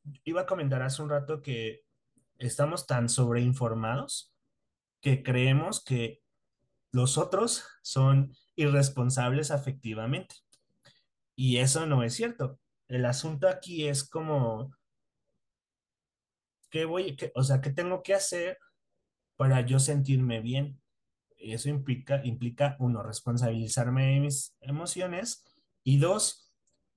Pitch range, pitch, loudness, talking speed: 125-150 Hz, 135 Hz, -29 LUFS, 115 wpm